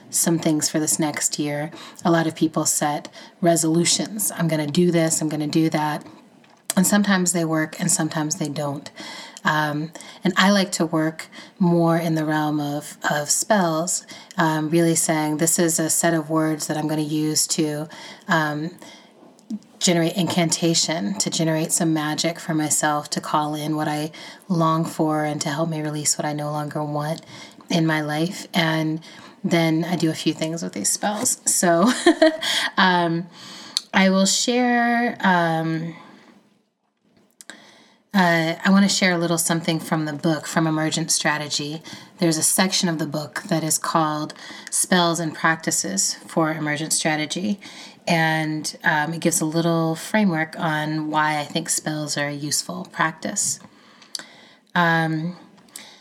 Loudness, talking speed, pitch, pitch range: -21 LUFS, 160 wpm, 165 Hz, 155-180 Hz